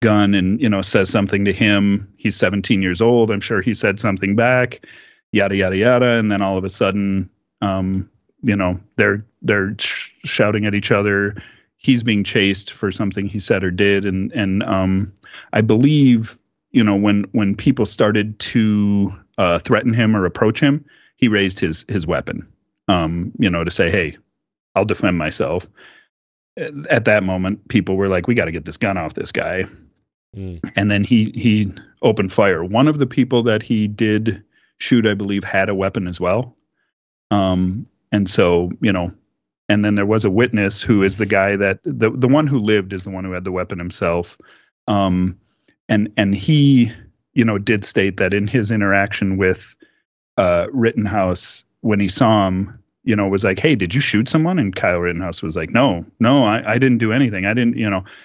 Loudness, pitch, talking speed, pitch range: -17 LUFS, 100 Hz, 195 wpm, 95-110 Hz